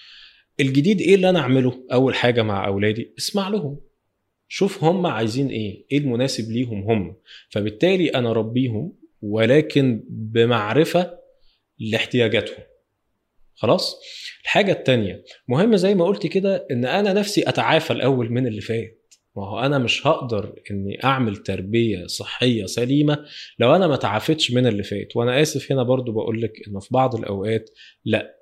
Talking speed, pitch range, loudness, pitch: 140 wpm, 110-160 Hz, -21 LUFS, 125 Hz